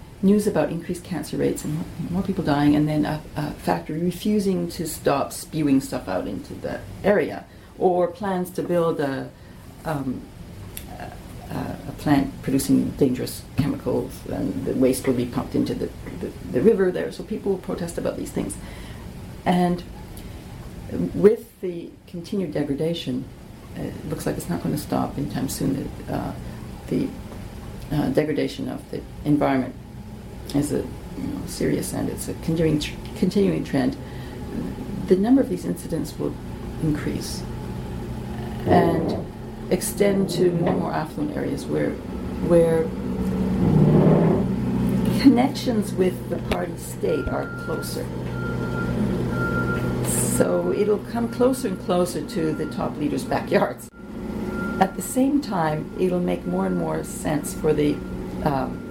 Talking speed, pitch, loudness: 140 wpm, 155 Hz, -24 LUFS